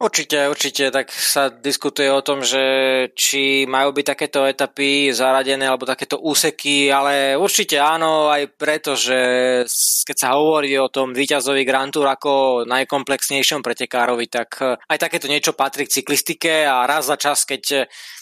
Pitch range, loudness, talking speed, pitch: 135-145 Hz, -17 LUFS, 150 wpm, 140 Hz